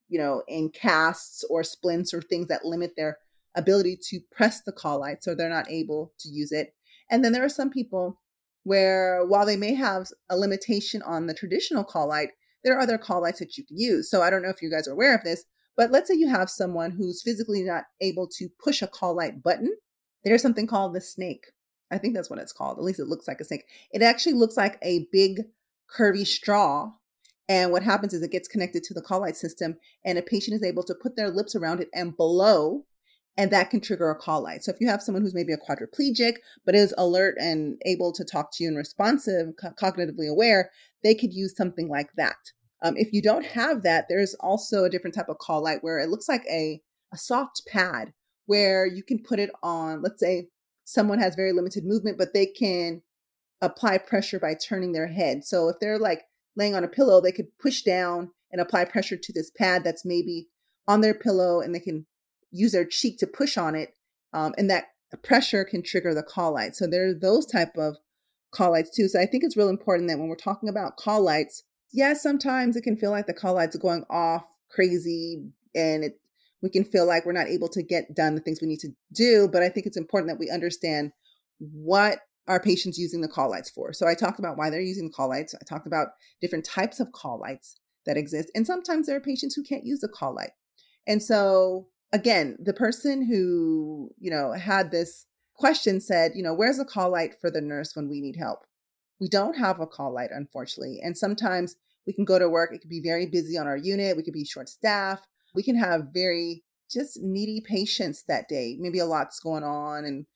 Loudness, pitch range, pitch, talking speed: -26 LUFS, 170-210 Hz, 185 Hz, 230 wpm